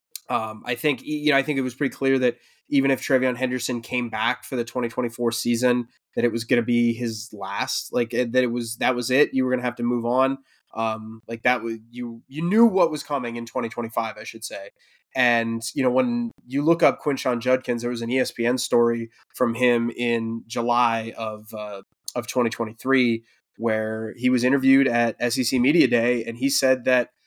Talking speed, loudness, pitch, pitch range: 220 wpm, -23 LUFS, 120 Hz, 115-130 Hz